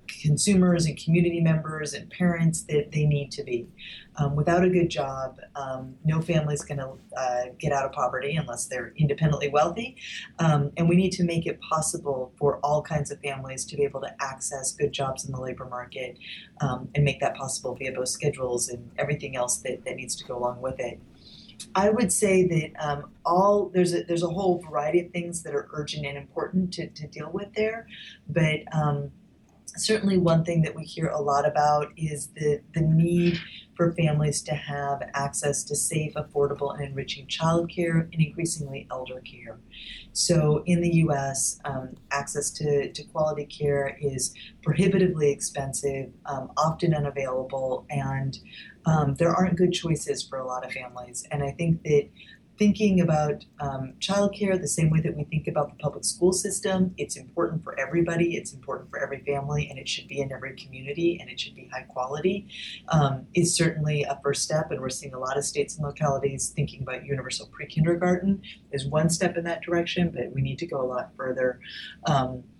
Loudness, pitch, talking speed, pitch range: -26 LUFS, 150 Hz, 190 wpm, 140-170 Hz